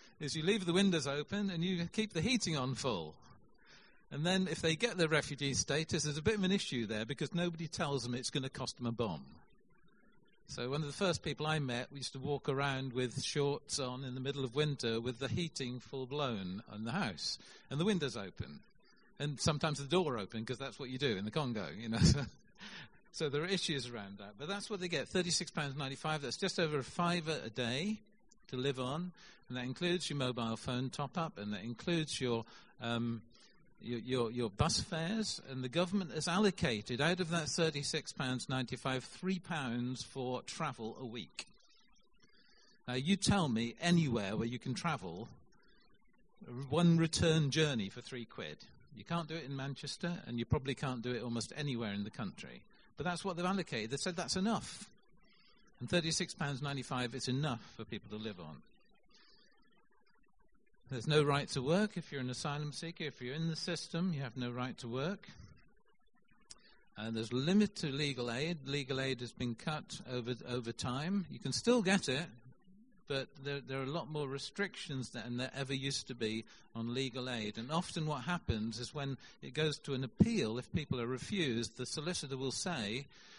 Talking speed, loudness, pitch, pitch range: 190 wpm, -37 LUFS, 140 Hz, 125-170 Hz